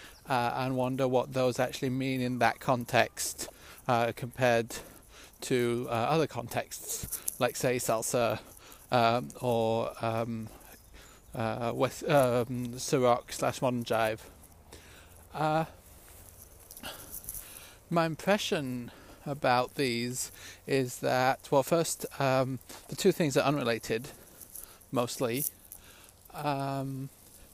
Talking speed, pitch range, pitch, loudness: 100 wpm, 110-130 Hz, 120 Hz, -30 LUFS